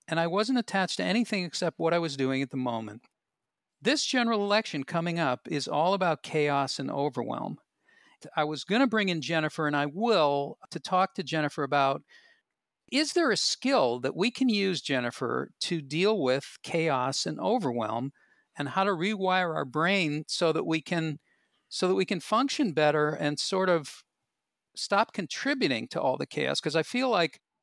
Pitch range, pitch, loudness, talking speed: 145-205 Hz, 165 Hz, -28 LUFS, 180 wpm